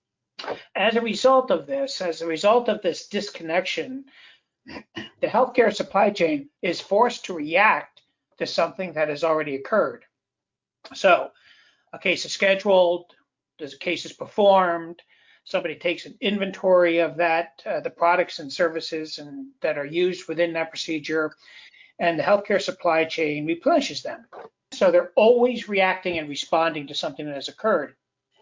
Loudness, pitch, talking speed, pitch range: -23 LUFS, 175 Hz, 150 wpm, 160-205 Hz